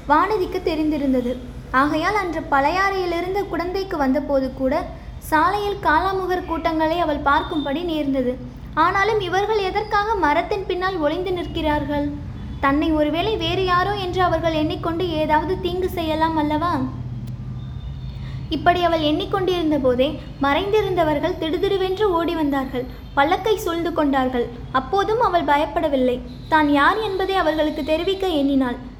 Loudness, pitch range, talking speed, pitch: -20 LUFS, 290-370 Hz, 110 wpm, 330 Hz